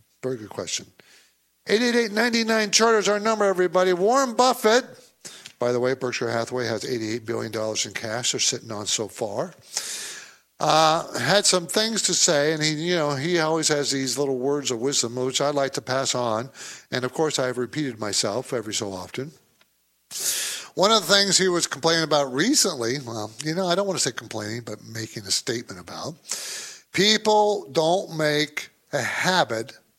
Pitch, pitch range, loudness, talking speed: 145 Hz, 120-190 Hz, -23 LUFS, 185 wpm